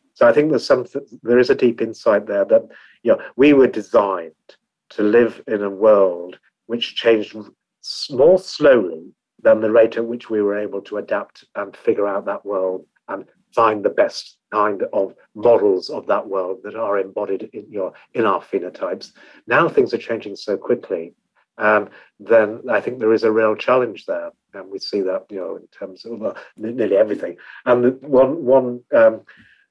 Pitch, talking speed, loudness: 125 Hz, 180 wpm, -18 LUFS